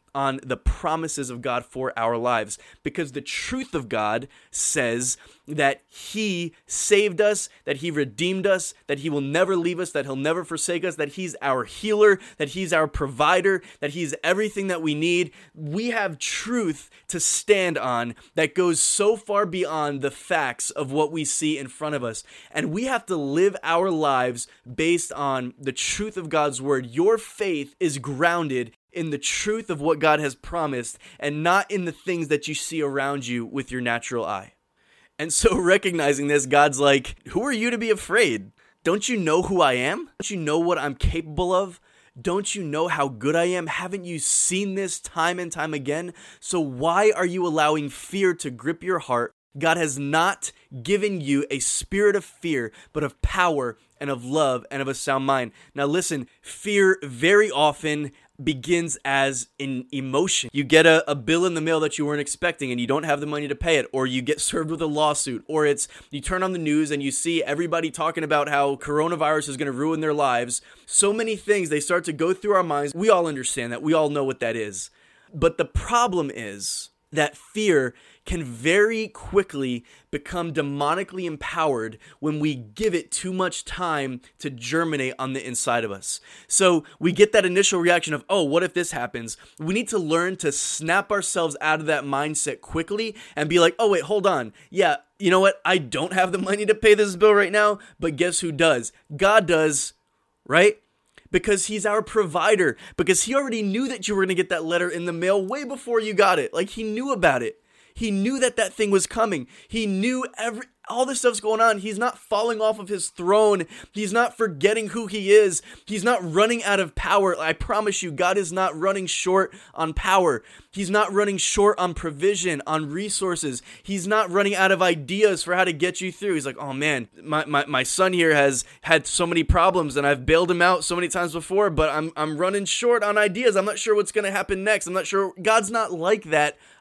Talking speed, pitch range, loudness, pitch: 205 wpm, 145-200 Hz, -23 LUFS, 170 Hz